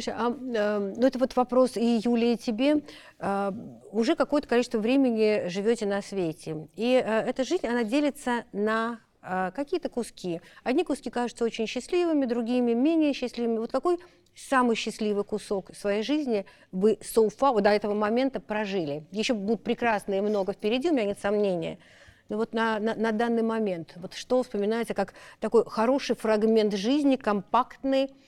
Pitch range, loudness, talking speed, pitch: 210-250 Hz, -27 LUFS, 160 wpm, 230 Hz